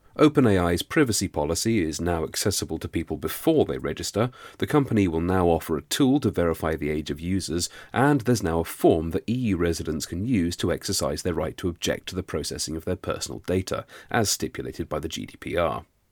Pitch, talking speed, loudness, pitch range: 90 Hz, 195 wpm, -25 LUFS, 80-110 Hz